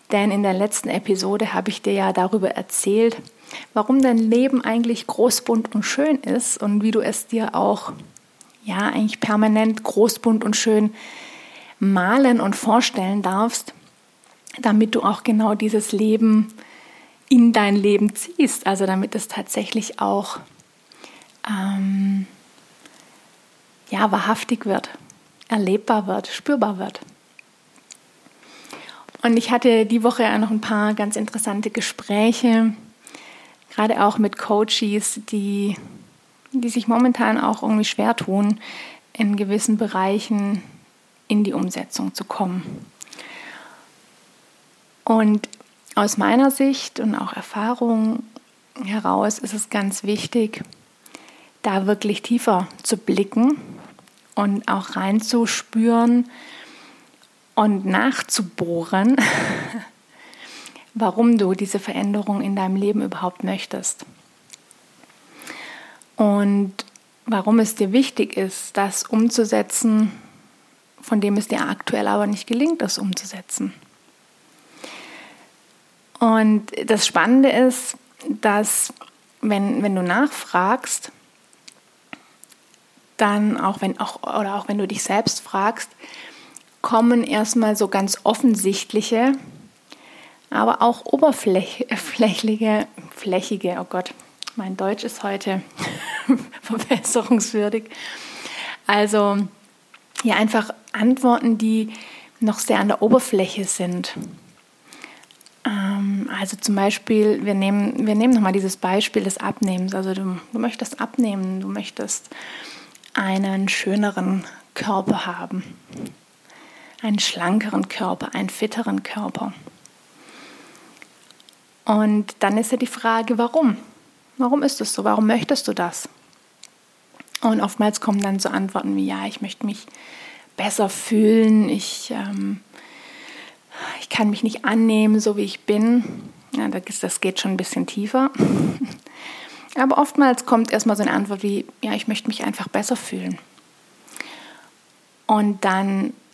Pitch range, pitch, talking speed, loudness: 205-240 Hz, 220 Hz, 115 wpm, -20 LUFS